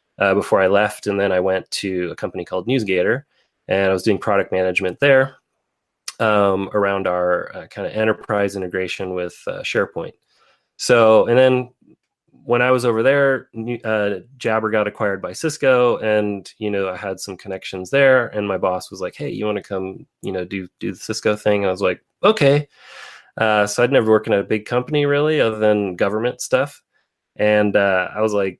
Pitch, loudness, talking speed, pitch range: 105 Hz, -19 LUFS, 195 wpm, 95-120 Hz